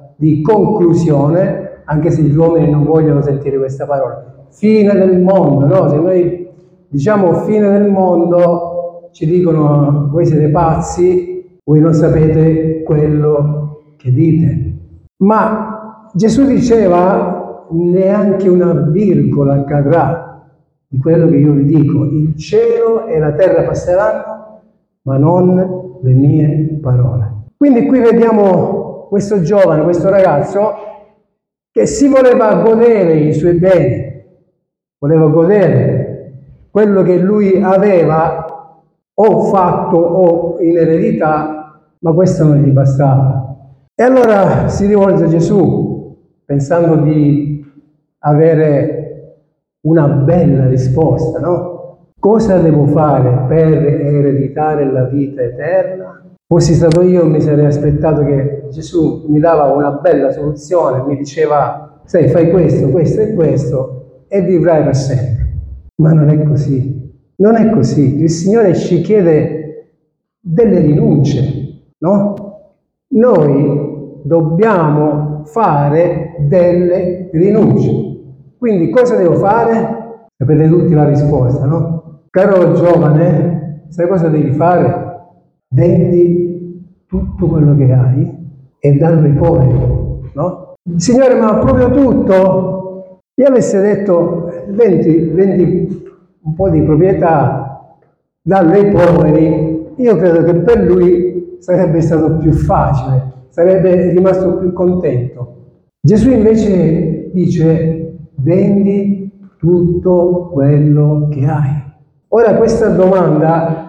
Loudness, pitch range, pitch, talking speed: -11 LUFS, 150-185 Hz, 165 Hz, 115 wpm